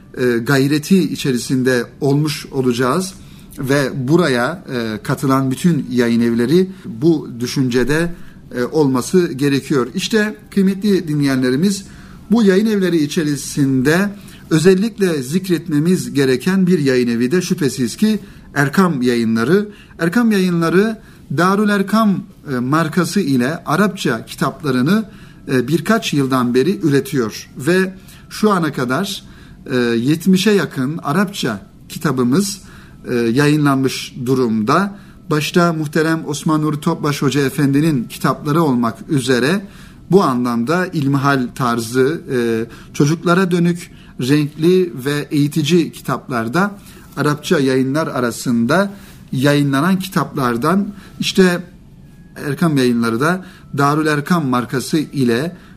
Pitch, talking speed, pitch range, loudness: 155 Hz, 95 wpm, 130-185 Hz, -16 LUFS